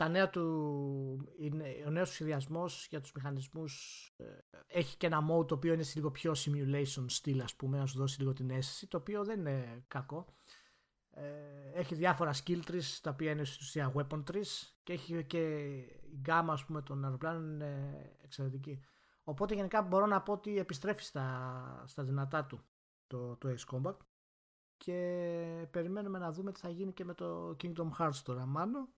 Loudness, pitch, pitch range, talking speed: -38 LUFS, 155 Hz, 135-175 Hz, 170 wpm